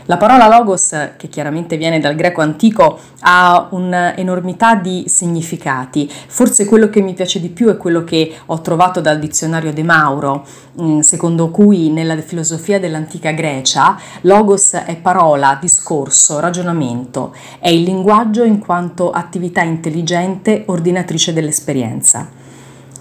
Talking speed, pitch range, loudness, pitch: 130 wpm, 155-185 Hz, -12 LUFS, 170 Hz